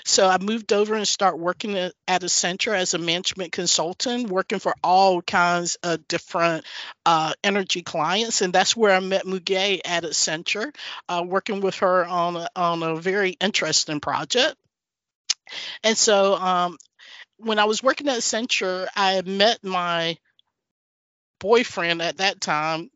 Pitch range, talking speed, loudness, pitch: 170-200 Hz, 155 wpm, -22 LUFS, 185 Hz